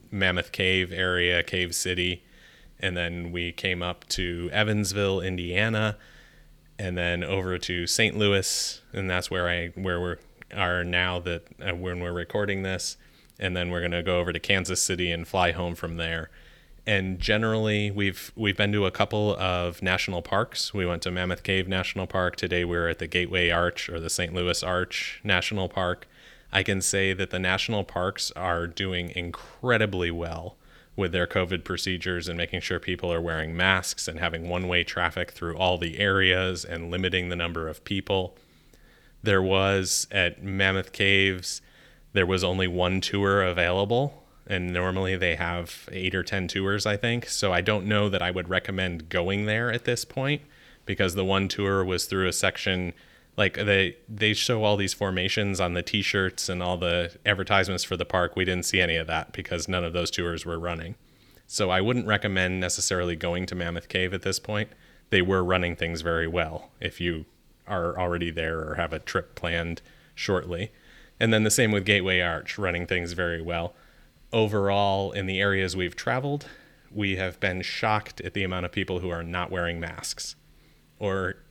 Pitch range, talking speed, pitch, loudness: 85-100 Hz, 185 wpm, 90 Hz, -26 LUFS